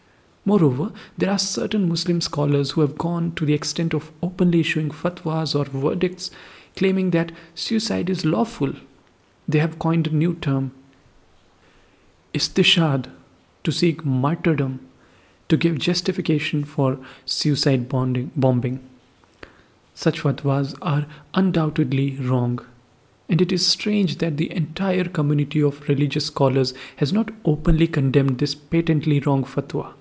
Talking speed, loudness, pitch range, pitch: 125 wpm, -21 LUFS, 135-170 Hz, 150 Hz